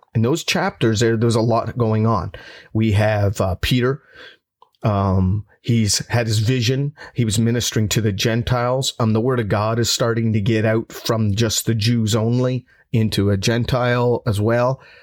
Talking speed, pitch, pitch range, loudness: 175 wpm, 115 Hz, 110-120 Hz, -19 LUFS